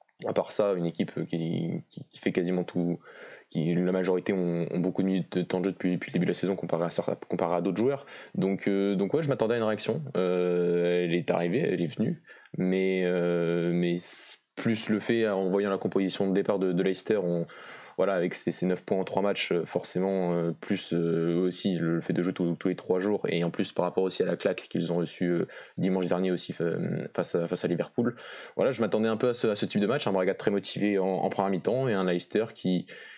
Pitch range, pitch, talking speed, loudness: 85-95 Hz, 90 Hz, 240 wpm, -29 LUFS